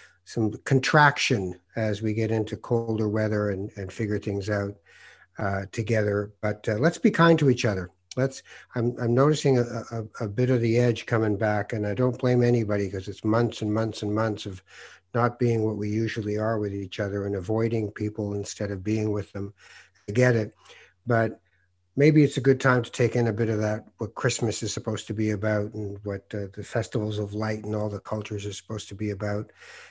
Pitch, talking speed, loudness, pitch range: 110 Hz, 210 wpm, -26 LUFS, 105-115 Hz